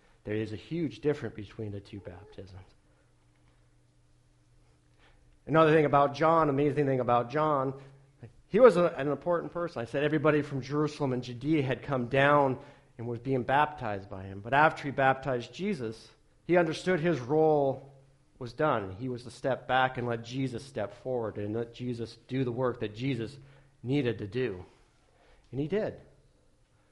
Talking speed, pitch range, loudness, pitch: 165 wpm, 110-145 Hz, -29 LUFS, 130 Hz